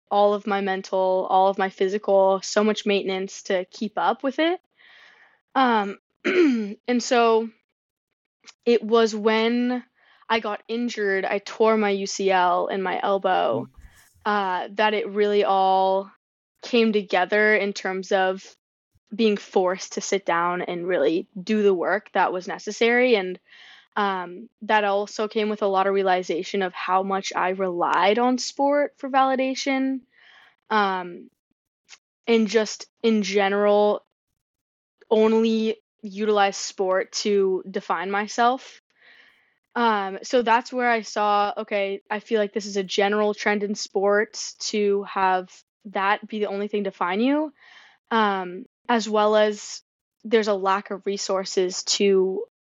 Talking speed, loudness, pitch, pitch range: 140 wpm, -23 LUFS, 210 Hz, 195-225 Hz